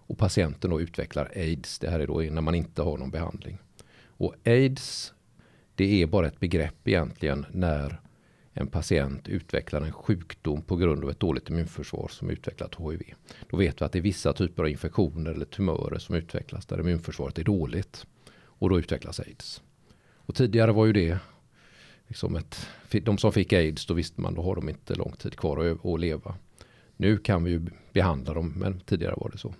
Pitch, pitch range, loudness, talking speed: 85 Hz, 80-100 Hz, -28 LUFS, 190 wpm